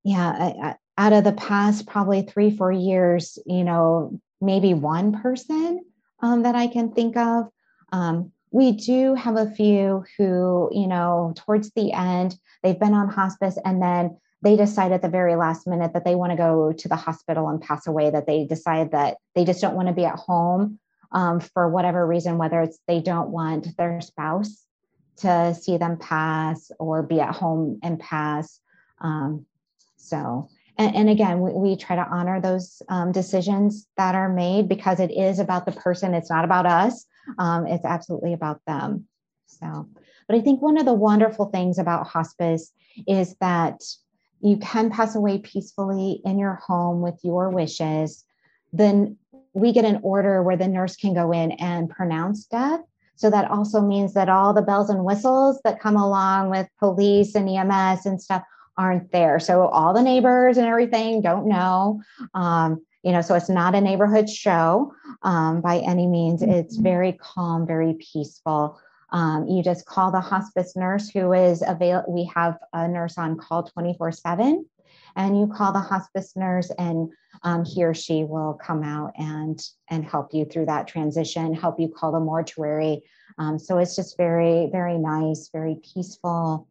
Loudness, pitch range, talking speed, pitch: -22 LUFS, 165-200 Hz, 180 wpm, 180 Hz